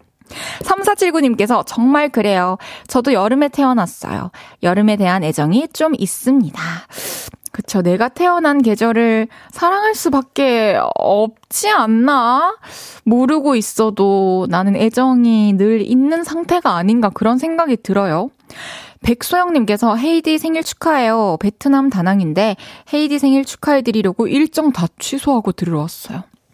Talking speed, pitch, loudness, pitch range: 285 characters per minute, 240 Hz, -15 LUFS, 210-295 Hz